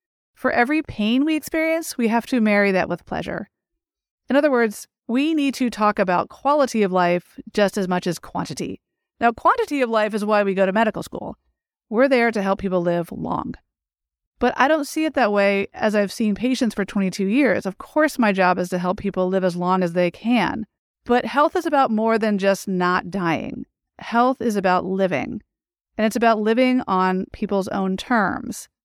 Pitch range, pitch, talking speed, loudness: 190-255 Hz, 215 Hz, 200 wpm, -21 LUFS